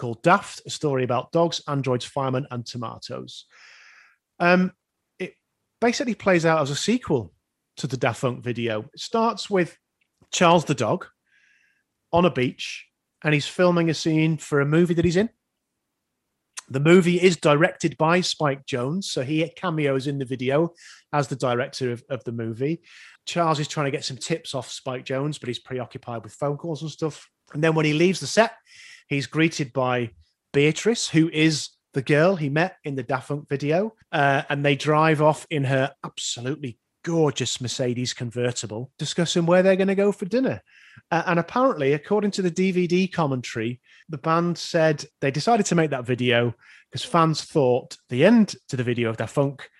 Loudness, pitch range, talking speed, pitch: -23 LUFS, 130-175 Hz, 180 wpm, 155 Hz